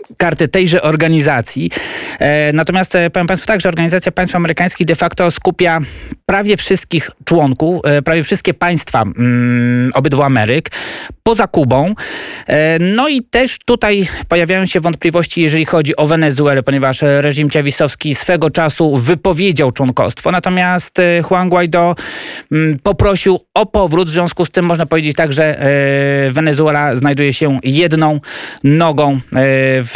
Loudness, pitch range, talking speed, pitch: -12 LUFS, 145-180 Hz, 125 wpm, 165 Hz